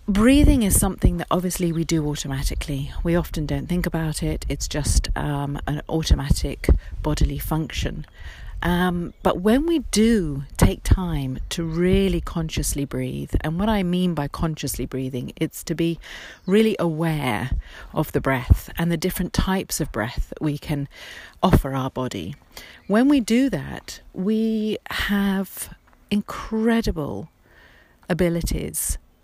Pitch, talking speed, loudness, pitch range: 165 Hz, 140 wpm, -23 LUFS, 140-190 Hz